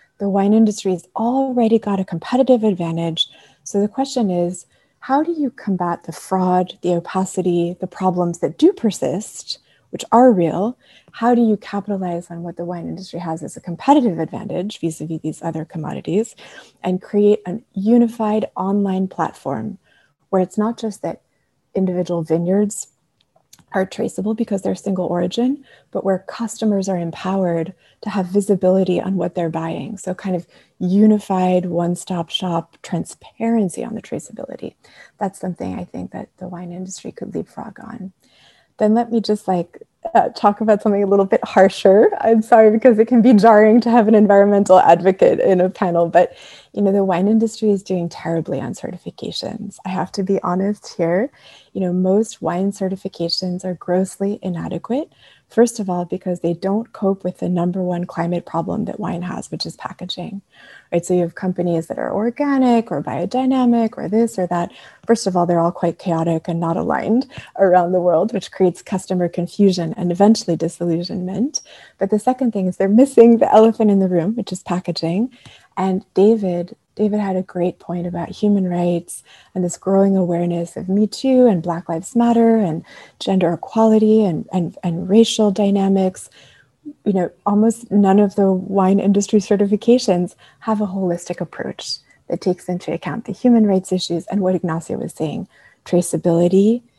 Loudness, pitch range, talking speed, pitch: -18 LUFS, 175-215 Hz, 175 wpm, 190 Hz